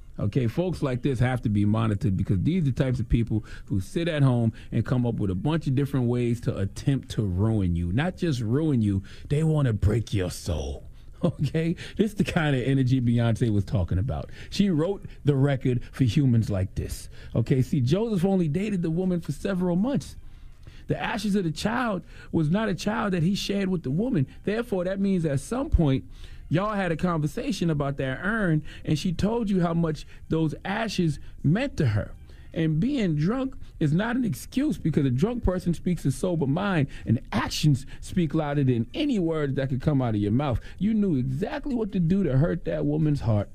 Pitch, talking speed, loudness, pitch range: 150 Hz, 210 wpm, -26 LUFS, 120-180 Hz